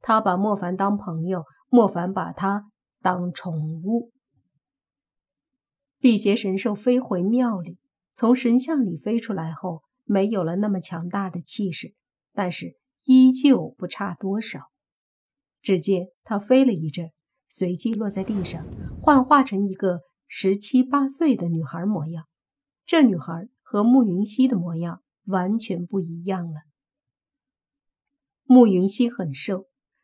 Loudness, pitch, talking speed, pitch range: -22 LUFS, 200 Hz, 190 characters per minute, 180-250 Hz